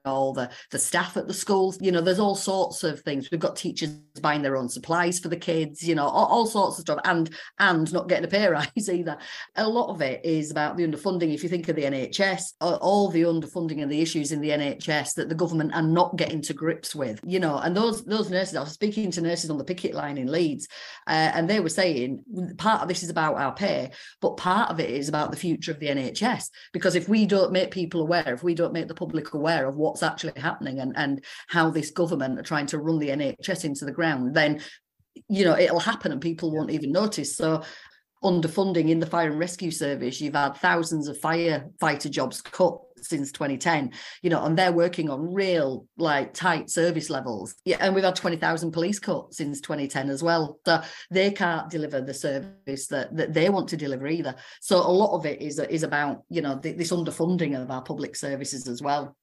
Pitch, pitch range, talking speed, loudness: 165 Hz, 150-180 Hz, 225 wpm, -26 LUFS